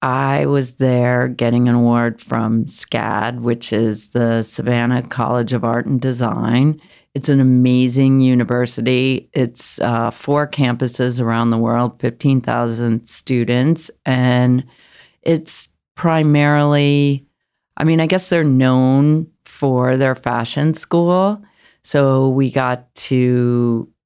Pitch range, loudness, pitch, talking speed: 120-140 Hz, -16 LUFS, 125 Hz, 115 wpm